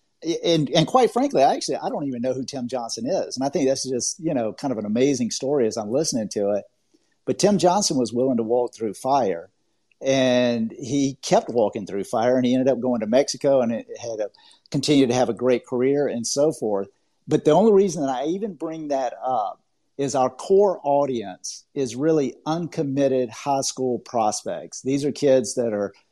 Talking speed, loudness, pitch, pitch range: 210 wpm, -22 LUFS, 135 Hz, 125-155 Hz